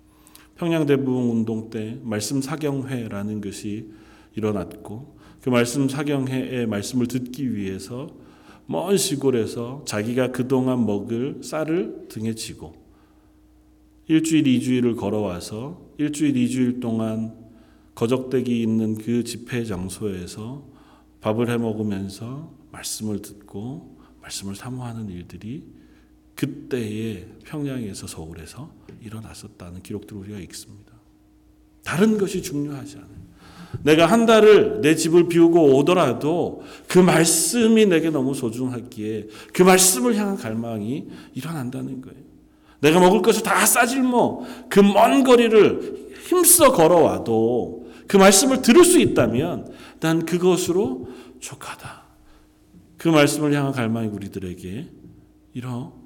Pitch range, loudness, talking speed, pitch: 105-155 Hz, -20 LUFS, 265 characters per minute, 120 Hz